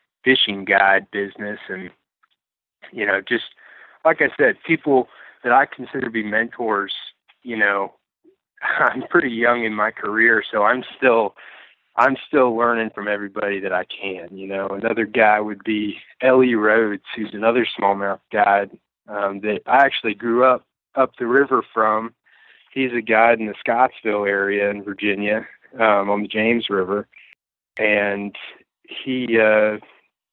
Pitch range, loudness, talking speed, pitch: 100-115 Hz, -19 LUFS, 150 wpm, 105 Hz